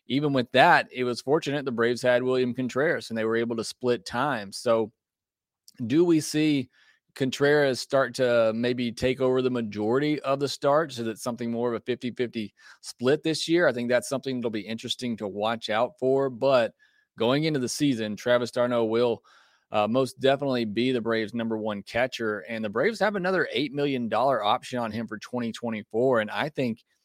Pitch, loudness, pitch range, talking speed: 125 Hz, -26 LUFS, 115-135 Hz, 195 wpm